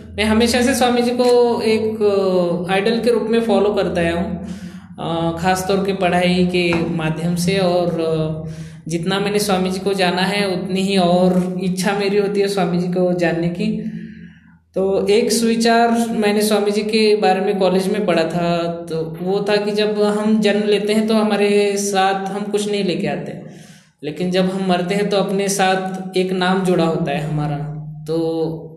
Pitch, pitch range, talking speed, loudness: 190 Hz, 175-205 Hz, 180 wpm, -17 LUFS